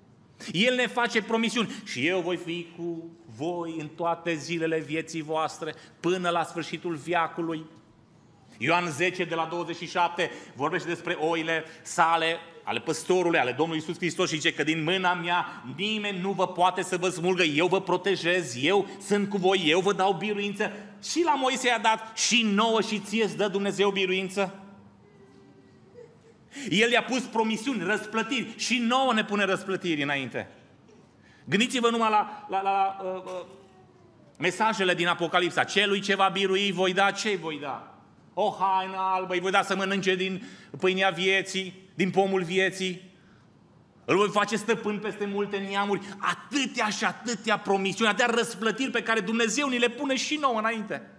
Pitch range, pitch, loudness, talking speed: 170-210 Hz, 190 Hz, -26 LUFS, 165 wpm